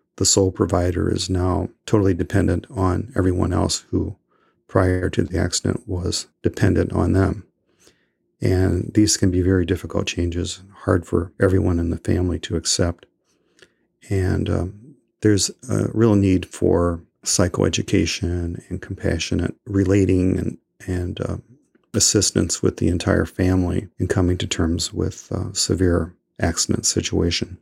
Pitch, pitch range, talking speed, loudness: 95 Hz, 90-105 Hz, 135 wpm, -21 LUFS